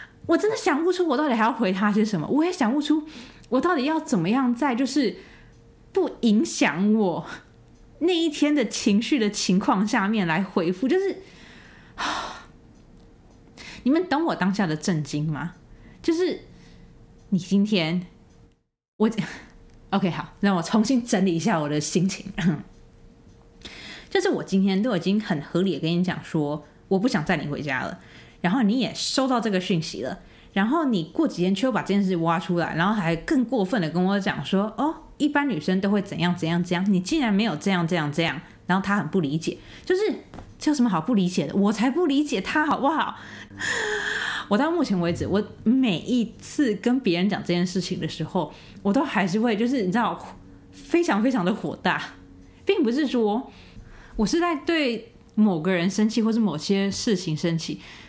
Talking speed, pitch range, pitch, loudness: 260 characters per minute, 180-265 Hz, 205 Hz, -24 LUFS